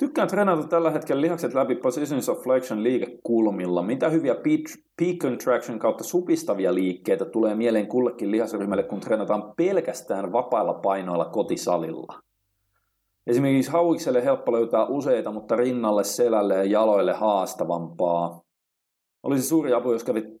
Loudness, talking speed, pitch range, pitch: -24 LUFS, 125 wpm, 100-160 Hz, 120 Hz